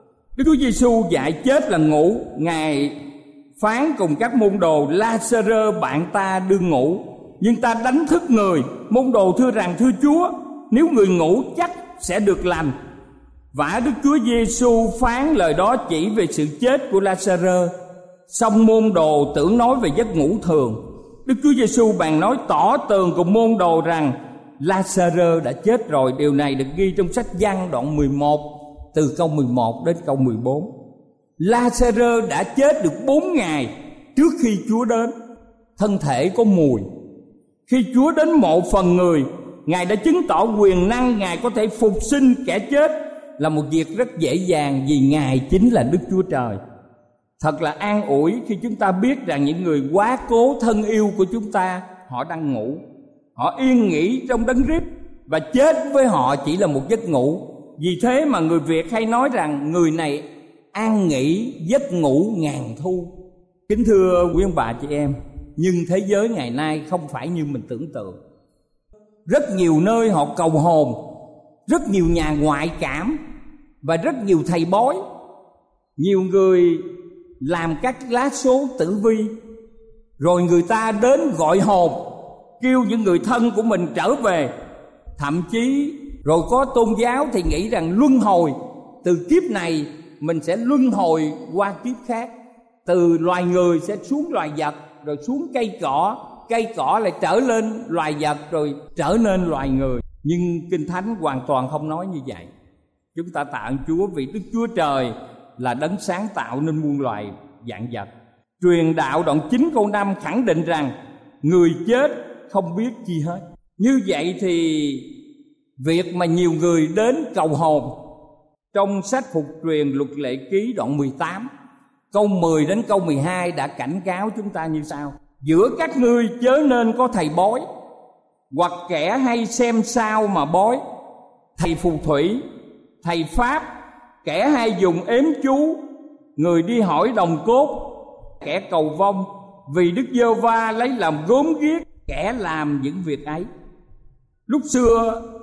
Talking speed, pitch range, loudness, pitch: 170 wpm, 155-240 Hz, -19 LUFS, 190 Hz